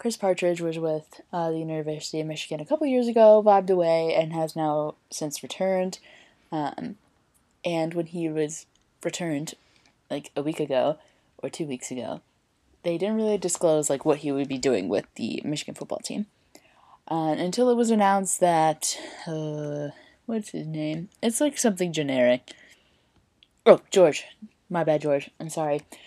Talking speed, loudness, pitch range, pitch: 160 wpm, -25 LUFS, 155-195 Hz, 165 Hz